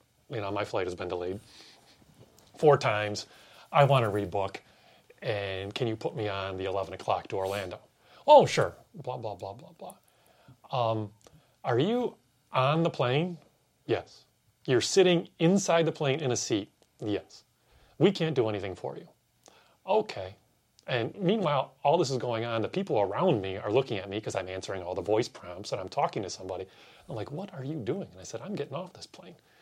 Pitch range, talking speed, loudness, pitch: 100-155 Hz, 190 wpm, -29 LUFS, 115 Hz